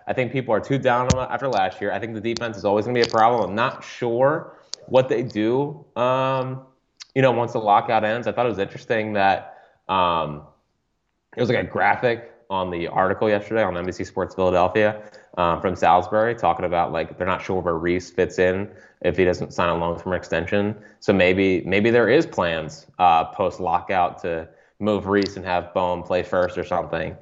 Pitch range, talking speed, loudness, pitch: 90-115 Hz, 205 wpm, -22 LUFS, 100 Hz